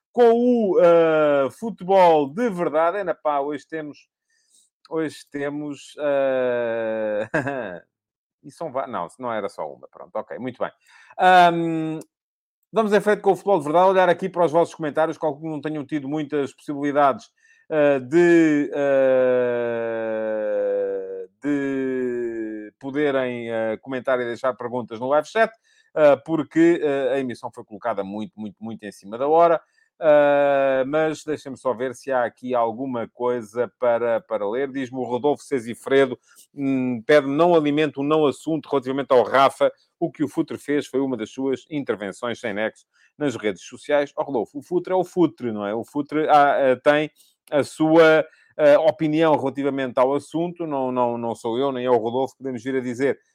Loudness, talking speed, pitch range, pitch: -21 LUFS, 165 wpm, 125-165 Hz, 145 Hz